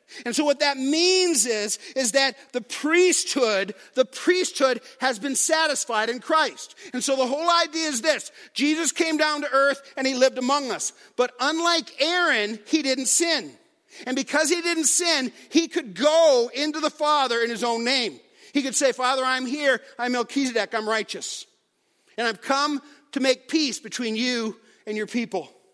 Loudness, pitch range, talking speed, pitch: -23 LUFS, 245-315 Hz, 175 wpm, 275 Hz